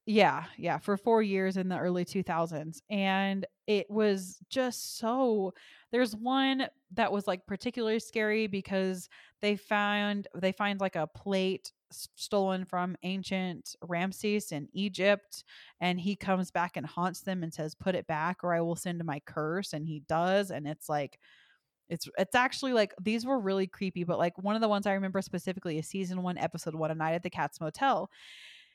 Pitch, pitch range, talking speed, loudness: 190 Hz, 170-205 Hz, 185 wpm, -32 LUFS